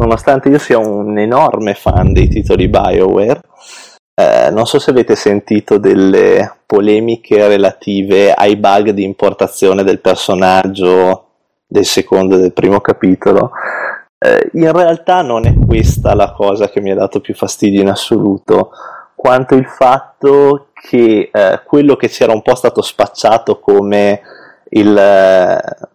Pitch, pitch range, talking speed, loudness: 105 Hz, 100-120 Hz, 140 wpm, -10 LUFS